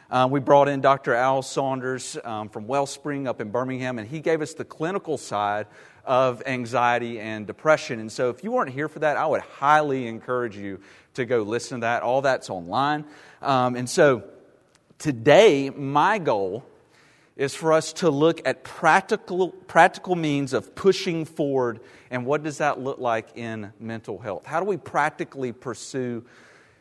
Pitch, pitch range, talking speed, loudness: 135 Hz, 120-150 Hz, 170 wpm, -24 LUFS